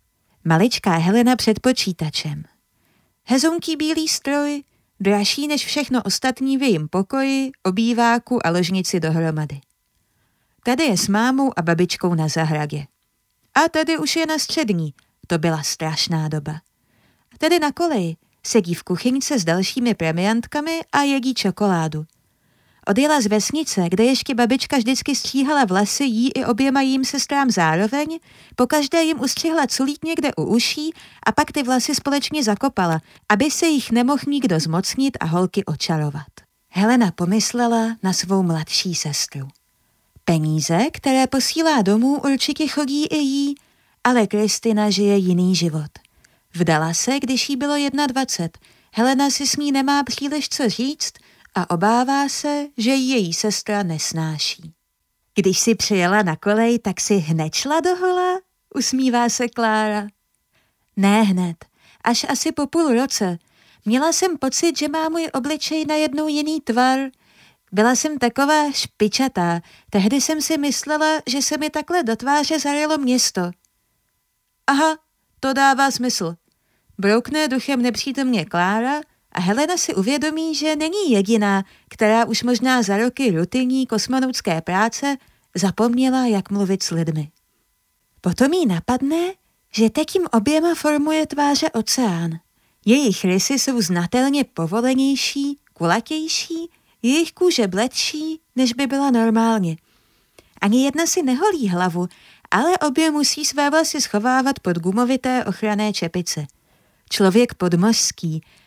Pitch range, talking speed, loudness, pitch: 190-285 Hz, 130 wpm, -19 LUFS, 245 Hz